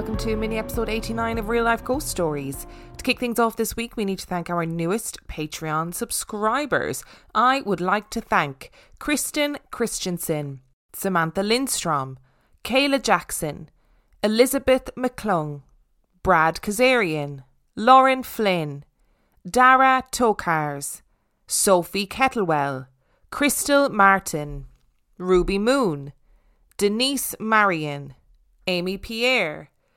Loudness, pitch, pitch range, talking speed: -22 LUFS, 195 Hz, 155-240 Hz, 105 wpm